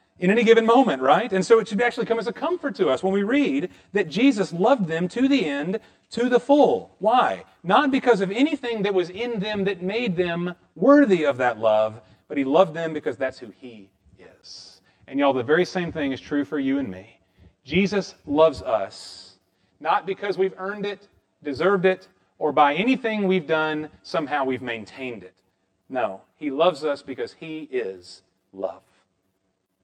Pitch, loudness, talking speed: 155 Hz, -22 LUFS, 185 wpm